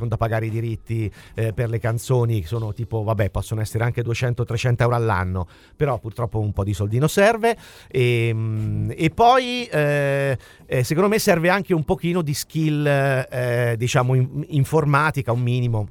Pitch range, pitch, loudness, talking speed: 110-145 Hz, 120 Hz, -21 LUFS, 160 wpm